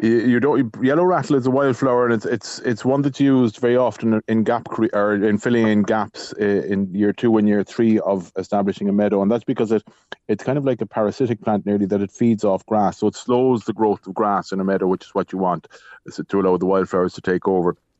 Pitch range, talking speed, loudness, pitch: 100-120 Hz, 245 wpm, -19 LUFS, 110 Hz